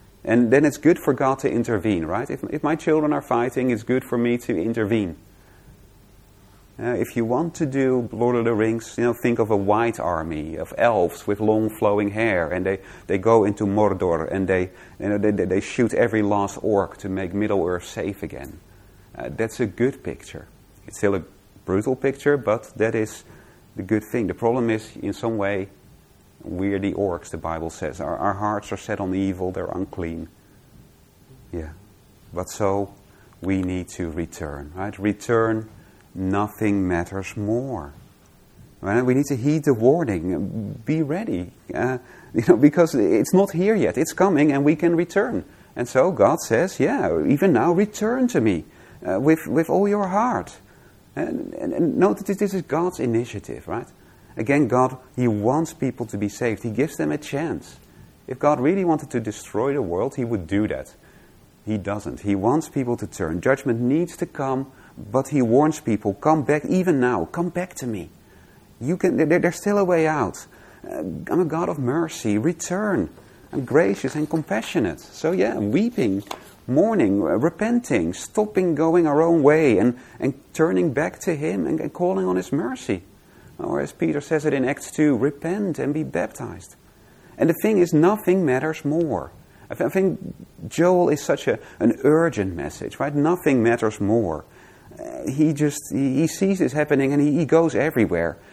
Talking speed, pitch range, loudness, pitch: 180 wpm, 100-150 Hz, -22 LUFS, 120 Hz